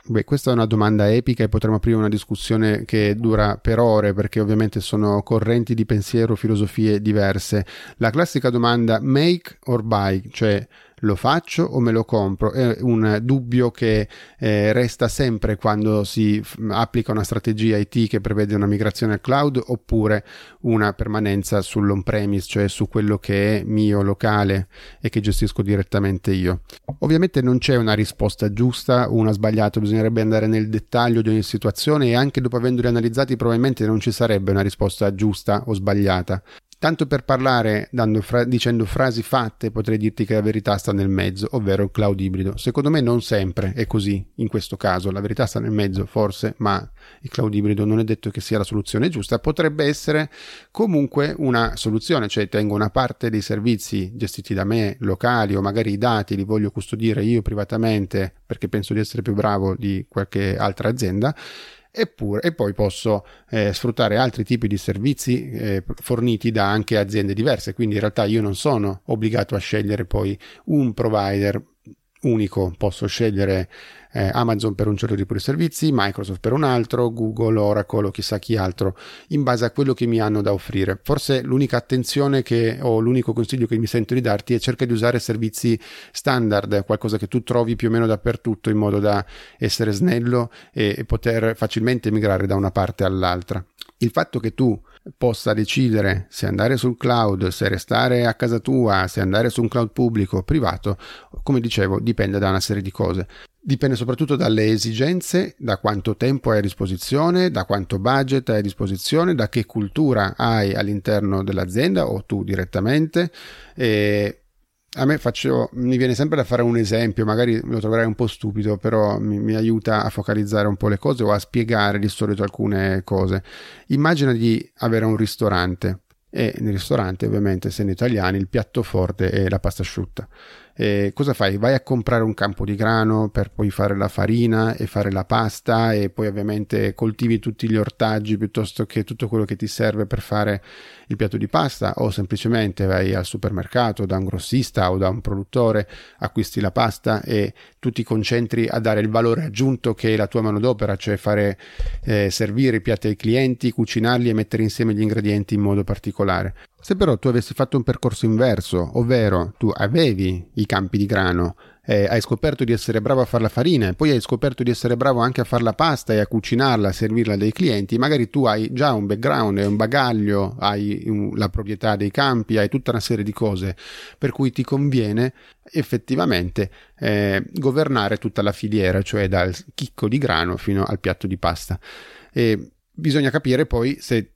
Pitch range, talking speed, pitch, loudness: 100-120 Hz, 185 wpm, 110 Hz, -20 LUFS